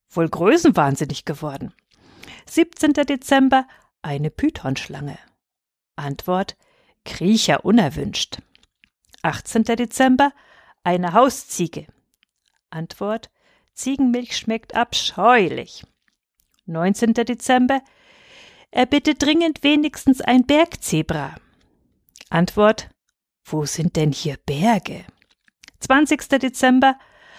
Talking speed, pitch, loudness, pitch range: 75 wpm, 235 Hz, -19 LUFS, 170-275 Hz